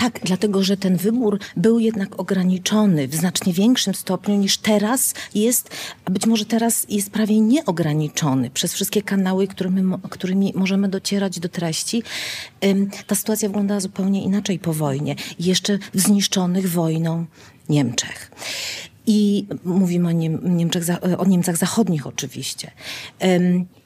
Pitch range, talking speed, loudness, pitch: 175-205 Hz, 130 wpm, -20 LUFS, 190 Hz